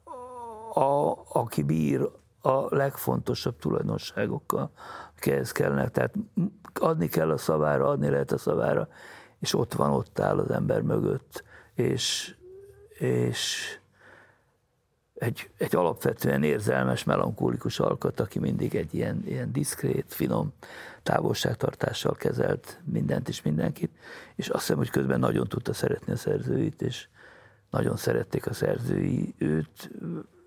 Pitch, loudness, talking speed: 135 Hz, -28 LUFS, 120 wpm